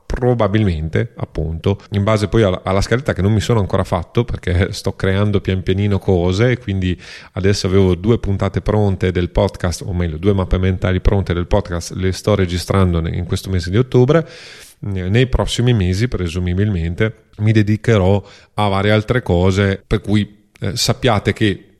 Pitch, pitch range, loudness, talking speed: 100 Hz, 95-110 Hz, -17 LUFS, 165 wpm